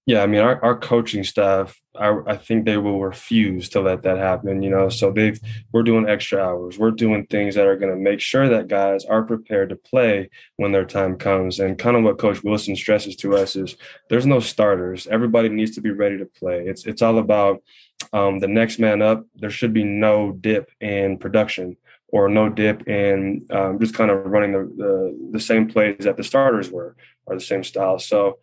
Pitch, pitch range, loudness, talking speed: 105 Hz, 95-110 Hz, -19 LUFS, 215 wpm